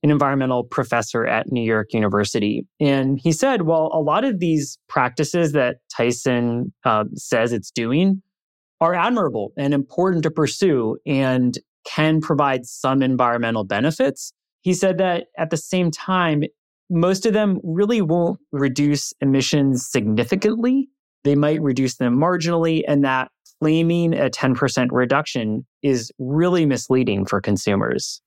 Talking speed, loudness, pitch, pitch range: 140 wpm, -20 LUFS, 145 Hz, 125-170 Hz